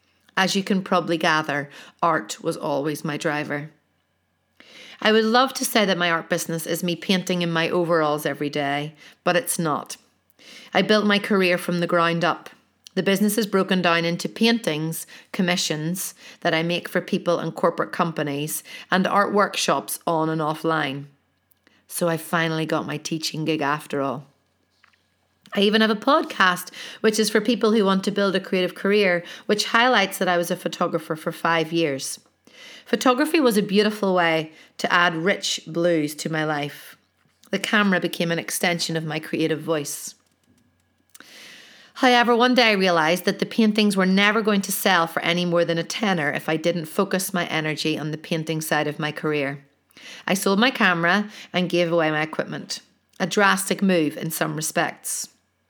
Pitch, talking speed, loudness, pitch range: 175 Hz, 175 wpm, -22 LUFS, 160-200 Hz